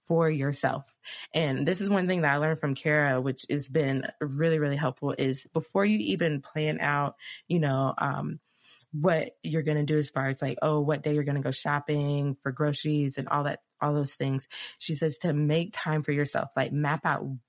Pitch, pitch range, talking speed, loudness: 150 Hz, 140-160 Hz, 215 wpm, -28 LUFS